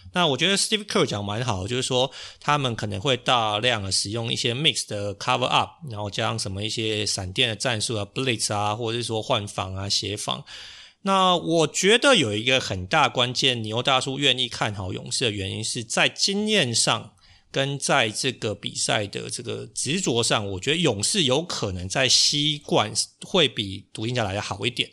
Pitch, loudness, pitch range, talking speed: 120 Hz, -23 LUFS, 105-135 Hz, 320 characters per minute